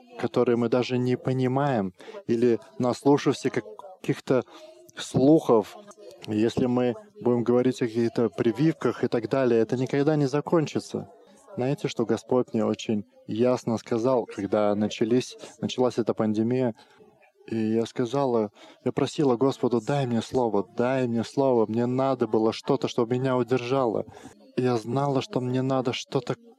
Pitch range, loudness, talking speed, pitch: 115-135 Hz, -26 LUFS, 140 wpm, 125 Hz